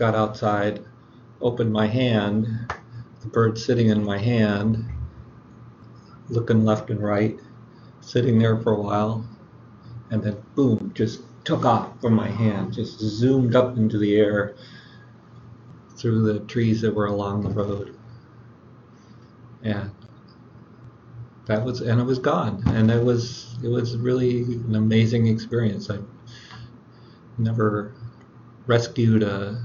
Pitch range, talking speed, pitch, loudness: 110-120 Hz, 130 wpm, 115 Hz, -23 LUFS